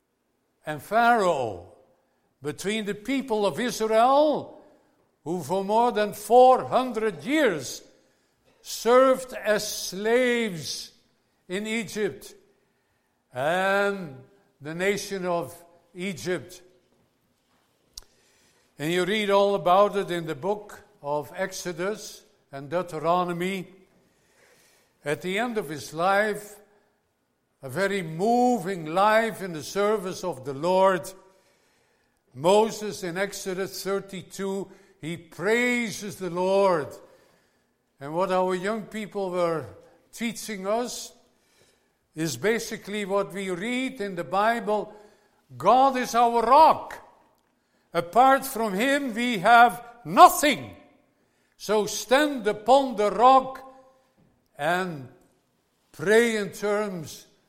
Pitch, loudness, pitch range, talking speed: 200 Hz, -24 LUFS, 180-230 Hz, 100 wpm